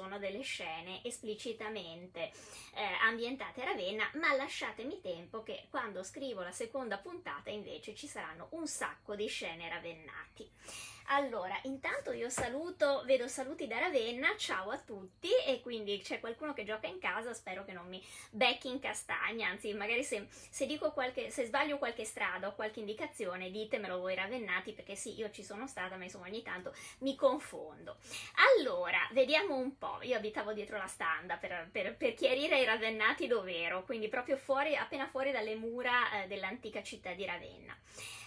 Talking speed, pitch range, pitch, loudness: 170 wpm, 195-270 Hz, 225 Hz, -36 LUFS